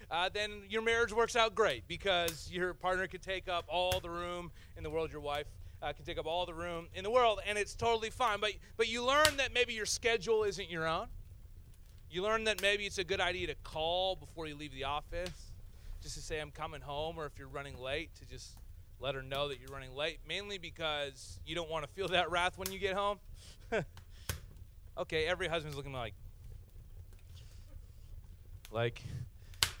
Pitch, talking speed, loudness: 160 Hz, 200 wpm, -36 LUFS